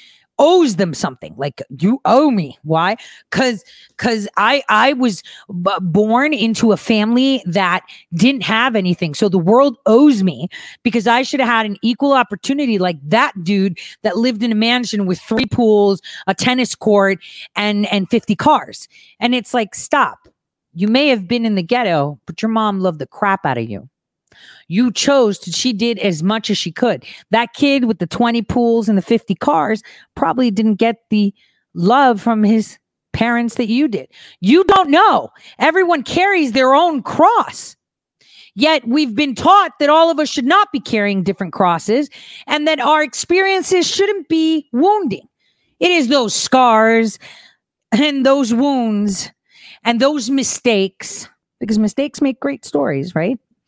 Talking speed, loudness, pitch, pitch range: 165 wpm, -15 LUFS, 230 Hz, 200-275 Hz